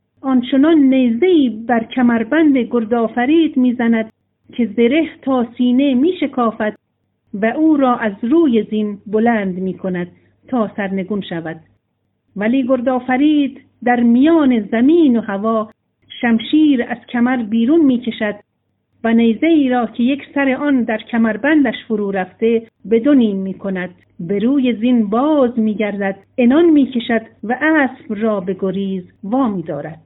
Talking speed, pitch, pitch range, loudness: 120 wpm, 235 Hz, 215-265 Hz, -16 LUFS